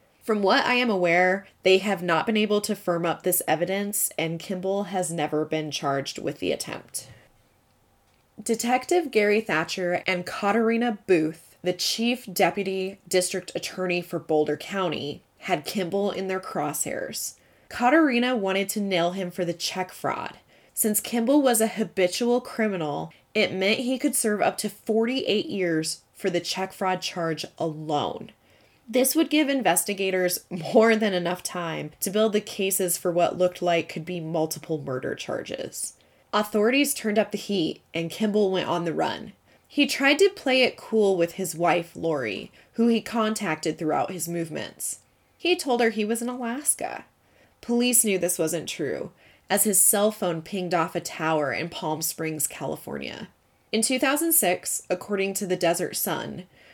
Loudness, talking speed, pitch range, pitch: -25 LUFS, 160 wpm, 175-220 Hz, 190 Hz